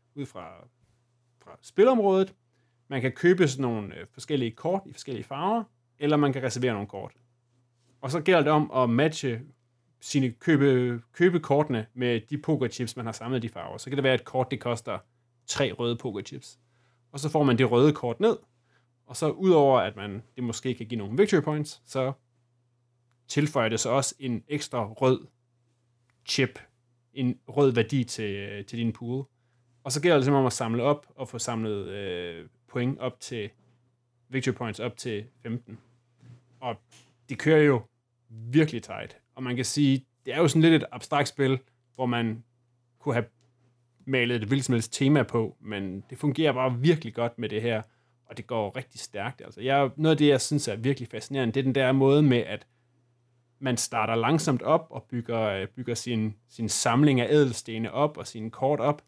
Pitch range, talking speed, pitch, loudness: 120-135 Hz, 185 wpm, 125 Hz, -26 LUFS